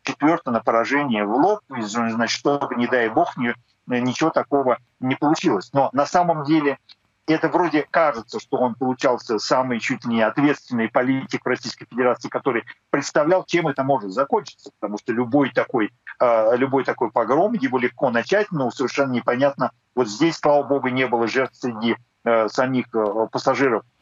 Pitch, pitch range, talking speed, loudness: 130 Hz, 120-145 Hz, 150 wpm, -21 LUFS